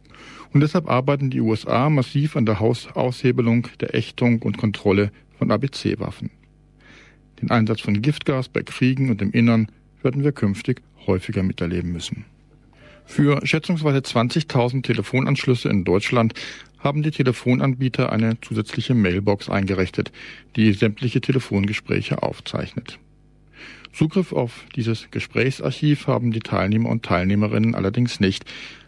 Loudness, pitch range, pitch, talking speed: -21 LUFS, 105-135 Hz, 120 Hz, 120 wpm